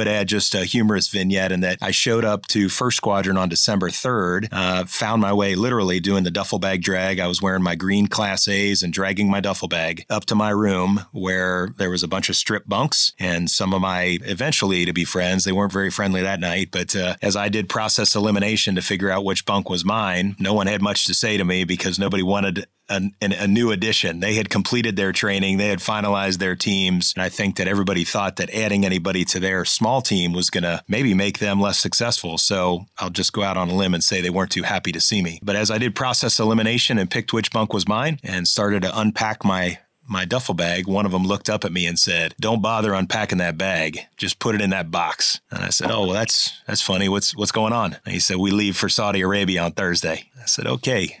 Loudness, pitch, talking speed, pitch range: -20 LUFS, 100 Hz, 245 wpm, 95-105 Hz